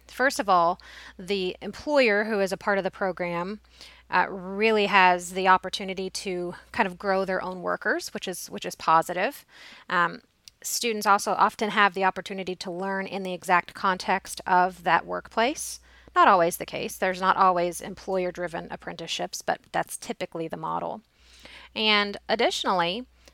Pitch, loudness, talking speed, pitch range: 190 Hz, -25 LUFS, 160 wpm, 180-205 Hz